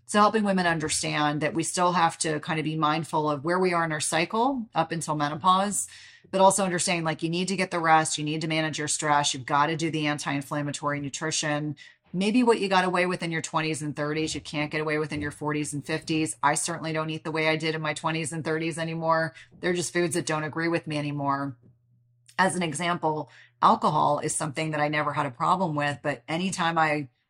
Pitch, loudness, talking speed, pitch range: 155 Hz, -26 LUFS, 235 wpm, 150-170 Hz